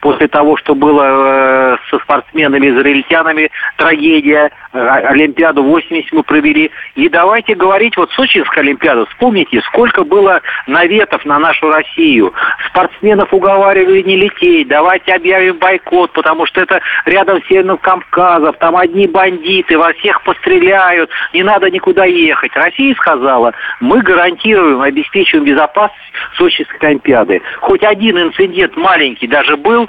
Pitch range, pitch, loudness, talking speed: 160-235 Hz, 185 Hz, -9 LUFS, 125 wpm